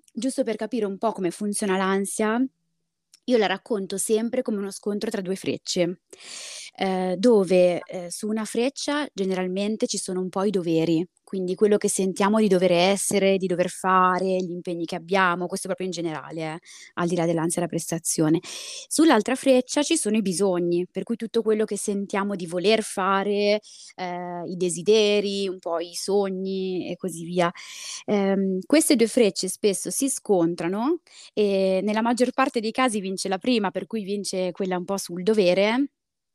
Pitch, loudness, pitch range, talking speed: 195 Hz, -24 LUFS, 180-220 Hz, 175 wpm